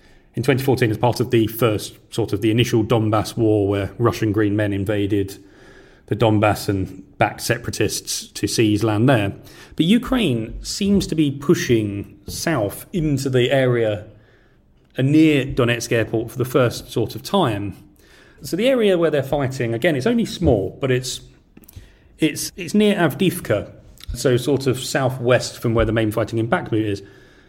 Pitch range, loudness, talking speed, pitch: 105-140 Hz, -20 LUFS, 160 wpm, 120 Hz